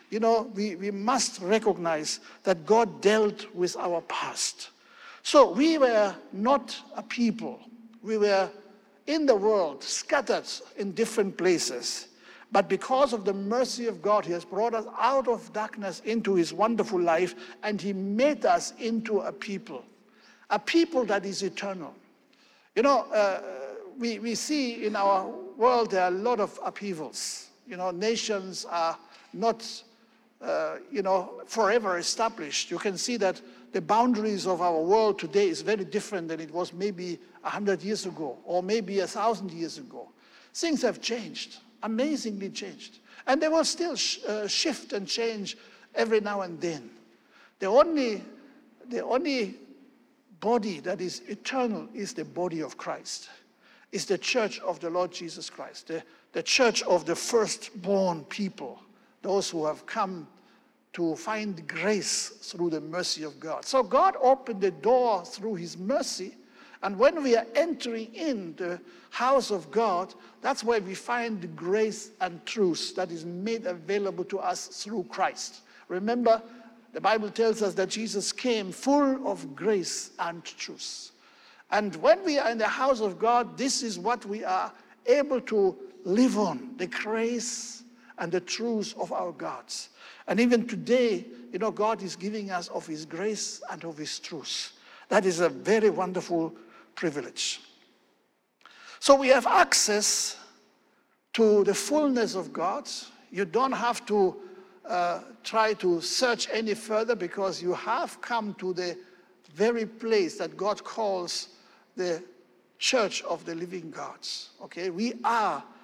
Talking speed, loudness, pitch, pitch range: 155 wpm, -28 LUFS, 210 Hz, 185-235 Hz